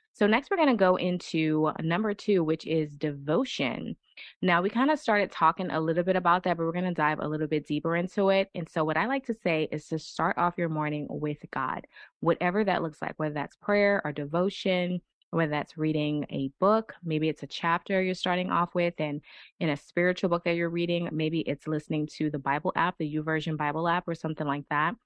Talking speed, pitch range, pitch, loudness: 225 wpm, 155-185 Hz, 170 Hz, -28 LUFS